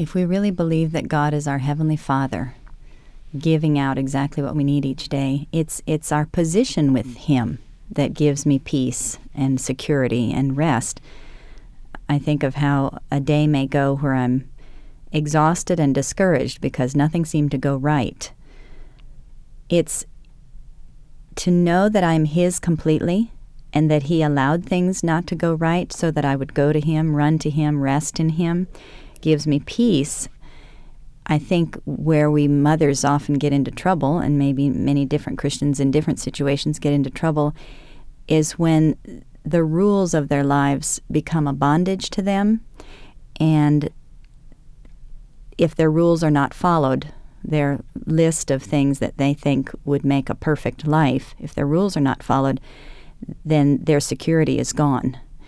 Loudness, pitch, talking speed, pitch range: -20 LUFS, 150 Hz, 155 wpm, 140-160 Hz